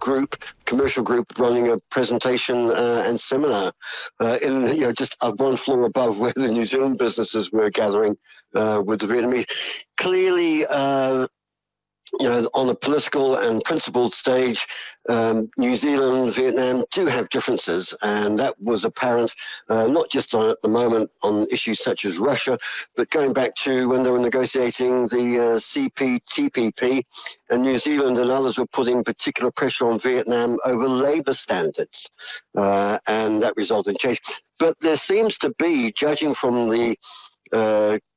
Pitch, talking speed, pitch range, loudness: 125 Hz, 160 wpm, 115-135 Hz, -21 LUFS